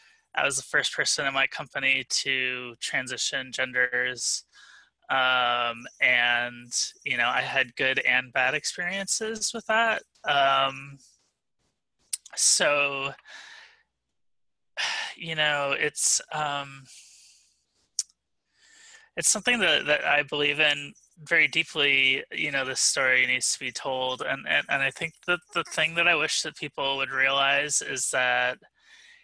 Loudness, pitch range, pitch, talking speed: -24 LUFS, 130-175 Hz, 145 Hz, 130 wpm